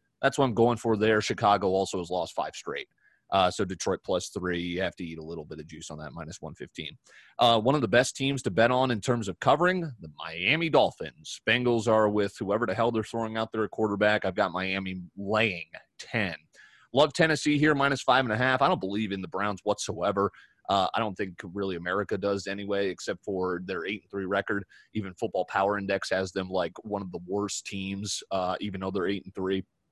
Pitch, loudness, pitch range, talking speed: 100 Hz, -28 LUFS, 95-115 Hz, 225 wpm